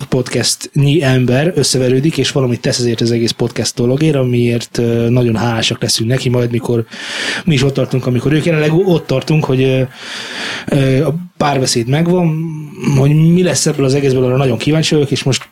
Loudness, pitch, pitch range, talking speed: -13 LUFS, 130 Hz, 125-155 Hz, 170 wpm